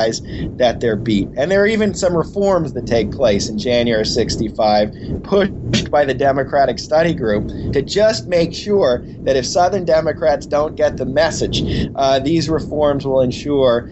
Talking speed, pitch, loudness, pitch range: 165 wpm, 145 Hz, -17 LUFS, 115-165 Hz